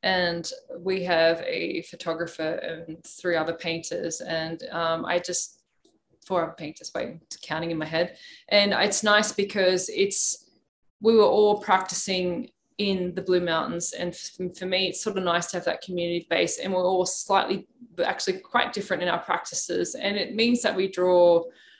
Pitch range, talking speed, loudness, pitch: 170-200 Hz, 170 wpm, -25 LUFS, 180 Hz